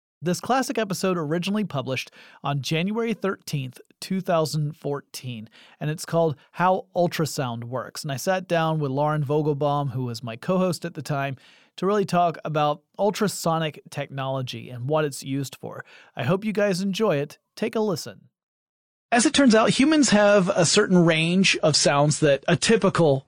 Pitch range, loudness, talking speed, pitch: 140-195 Hz, -23 LUFS, 165 wpm, 165 Hz